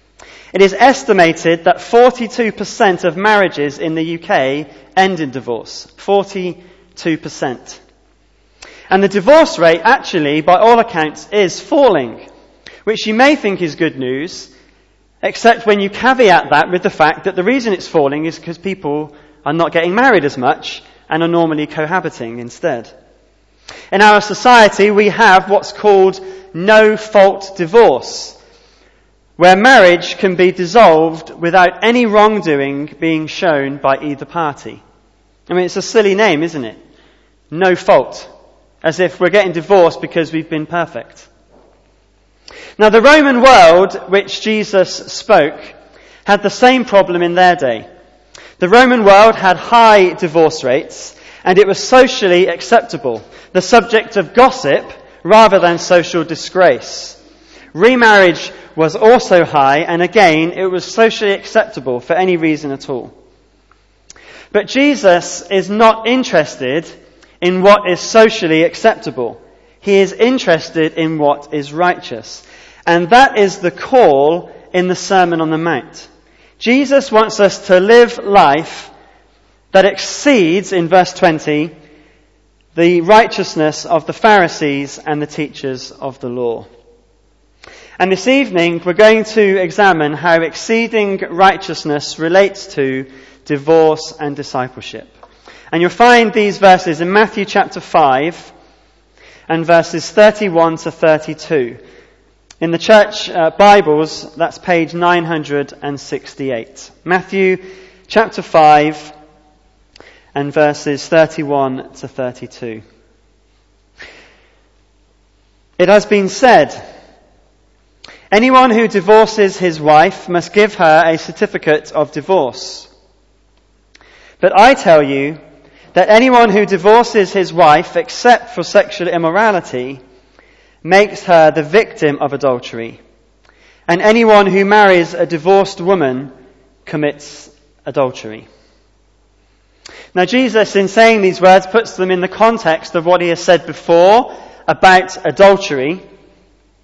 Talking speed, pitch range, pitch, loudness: 125 wpm, 155-205 Hz, 180 Hz, -11 LUFS